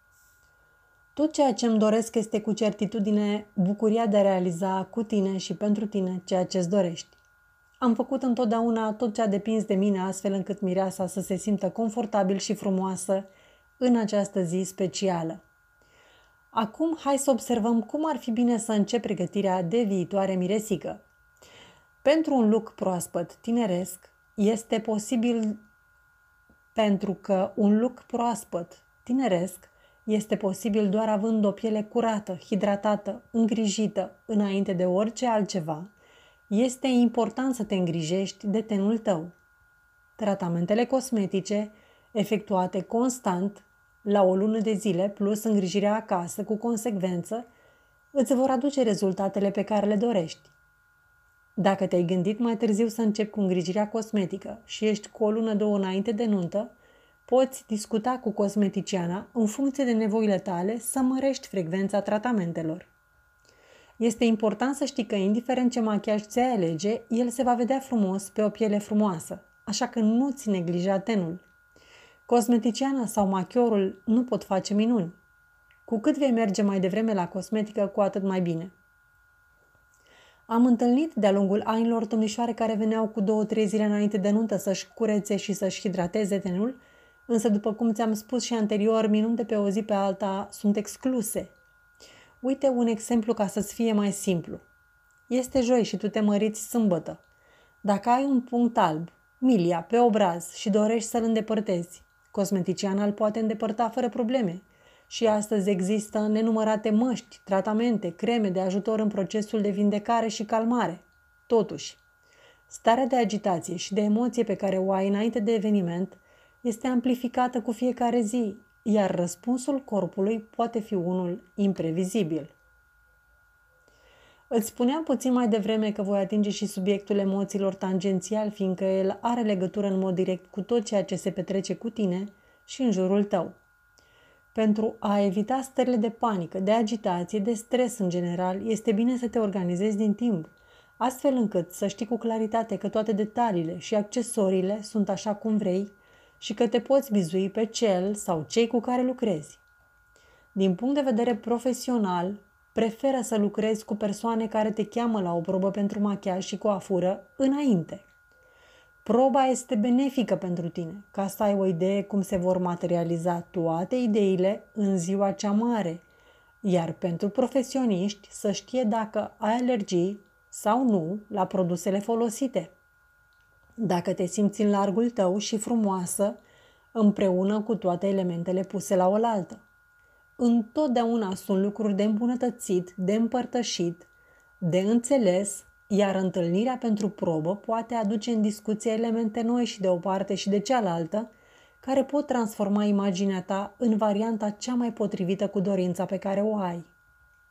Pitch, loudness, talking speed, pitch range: 215 Hz, -26 LUFS, 145 wpm, 195-240 Hz